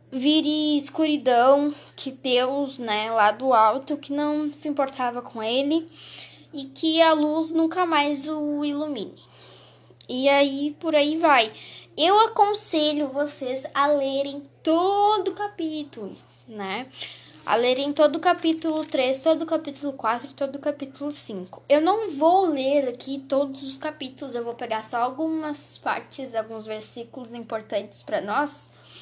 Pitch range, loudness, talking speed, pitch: 260-310 Hz, -23 LUFS, 145 wpm, 285 Hz